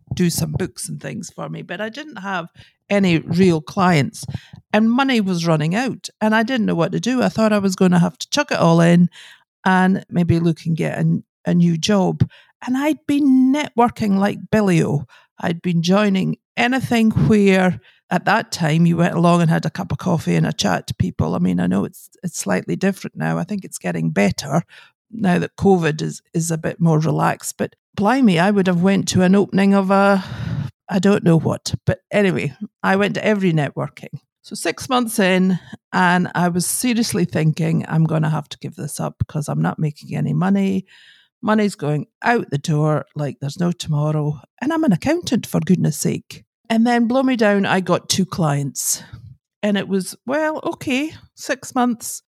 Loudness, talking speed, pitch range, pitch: -19 LUFS, 200 wpm, 160-210 Hz, 180 Hz